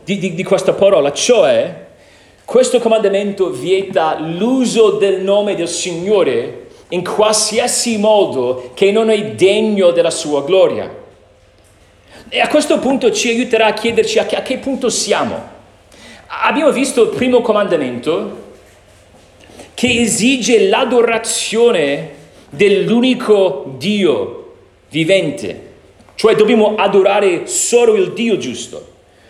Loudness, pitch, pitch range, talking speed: -13 LUFS, 215 Hz, 190-250 Hz, 115 wpm